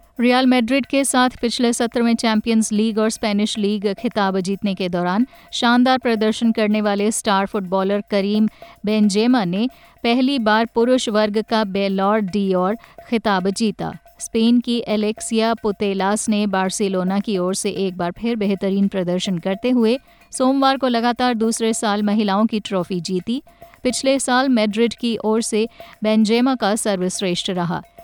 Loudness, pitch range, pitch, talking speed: -19 LUFS, 200-235 Hz, 220 Hz, 150 wpm